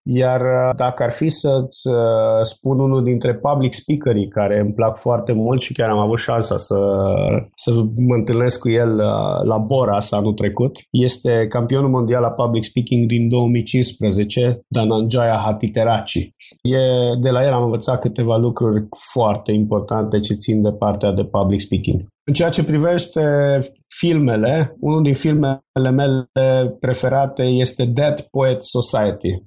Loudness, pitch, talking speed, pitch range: -18 LUFS, 120 Hz, 150 wpm, 110-130 Hz